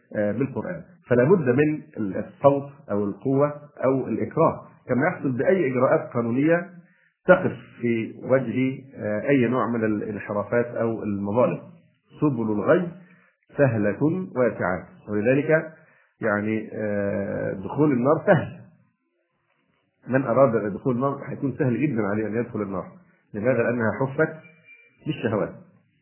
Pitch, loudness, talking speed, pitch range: 130 Hz, -24 LUFS, 110 wpm, 110-150 Hz